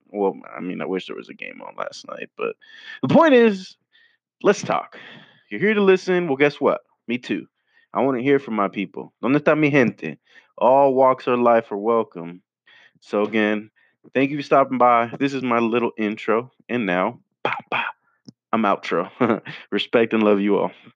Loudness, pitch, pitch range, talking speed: -20 LUFS, 125 Hz, 105-145 Hz, 190 wpm